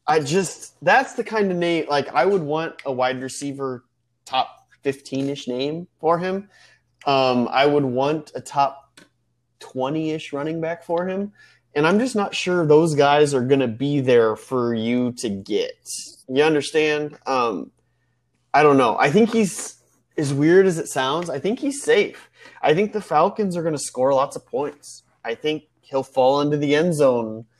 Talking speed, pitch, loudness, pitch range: 185 wpm, 145 Hz, -21 LUFS, 130-170 Hz